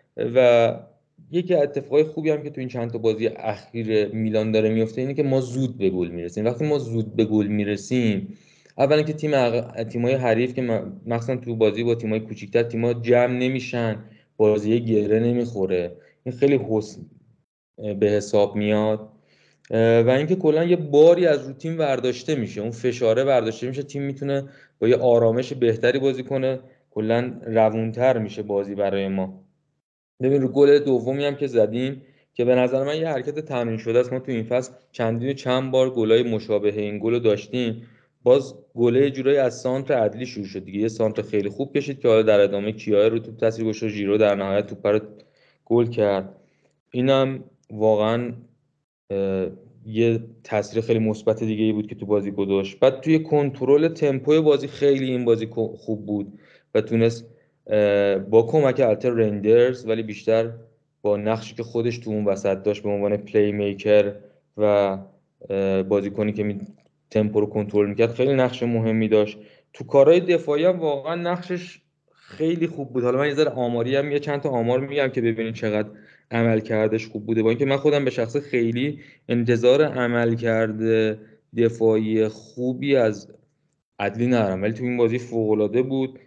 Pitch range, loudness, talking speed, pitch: 105-130 Hz, -22 LUFS, 165 wpm, 115 Hz